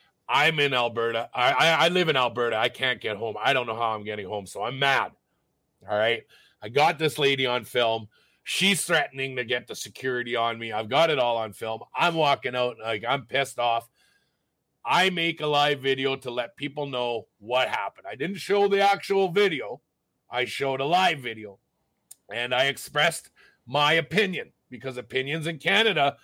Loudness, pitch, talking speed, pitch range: -25 LUFS, 130 Hz, 190 wpm, 115-160 Hz